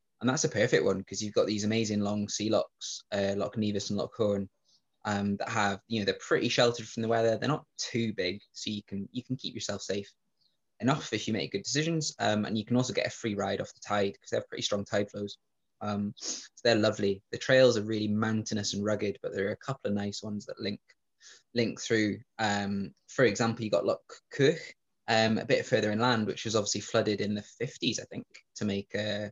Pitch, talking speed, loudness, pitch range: 105 Hz, 235 wpm, -30 LUFS, 100-115 Hz